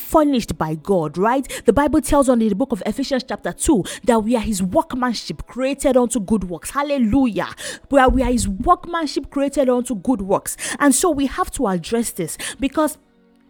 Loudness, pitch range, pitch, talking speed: -19 LUFS, 225-280 Hz, 255 Hz, 190 wpm